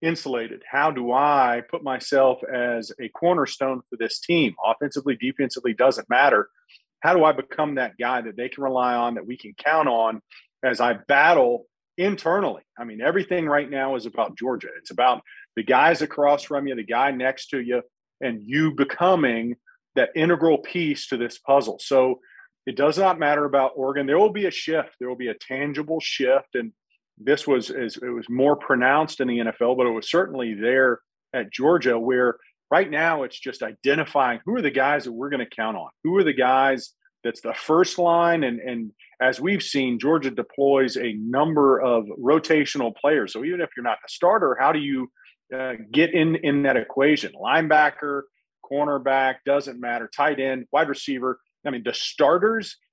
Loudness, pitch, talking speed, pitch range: -22 LUFS, 135 Hz, 185 wpm, 125-155 Hz